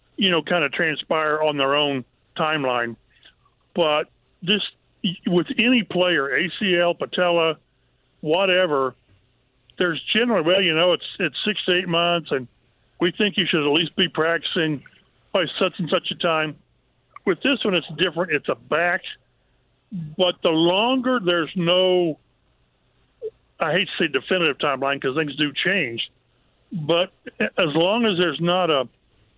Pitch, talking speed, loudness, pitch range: 170 Hz, 150 wpm, -21 LUFS, 150-185 Hz